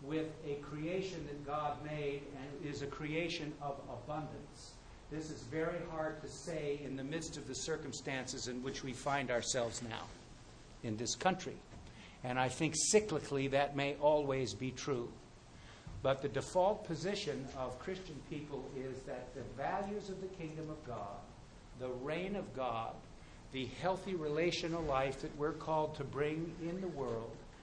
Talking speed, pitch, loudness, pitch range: 160 wpm, 145 Hz, -39 LUFS, 130-160 Hz